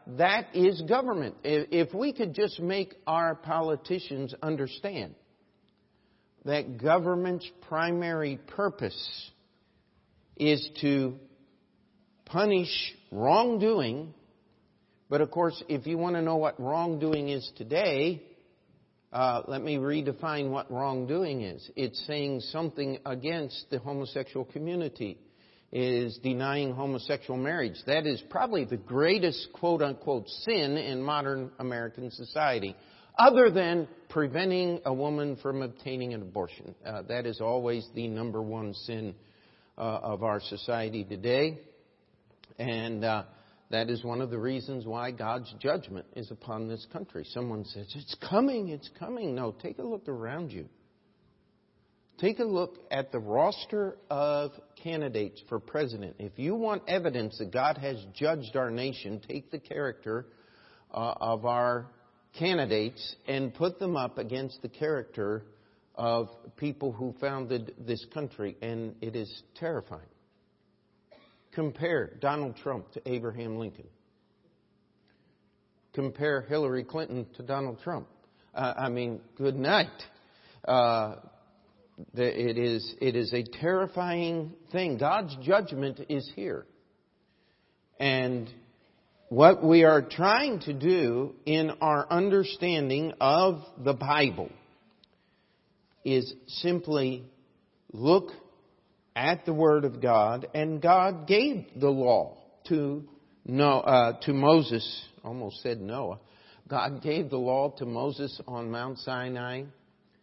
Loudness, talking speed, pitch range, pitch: -29 LUFS, 120 wpm, 120-160 Hz, 140 Hz